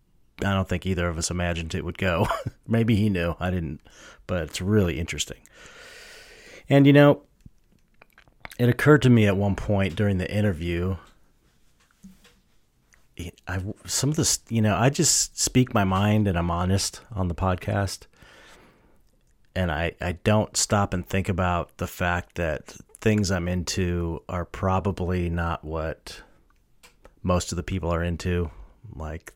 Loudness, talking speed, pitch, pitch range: -24 LUFS, 150 wpm, 95 Hz, 85-105 Hz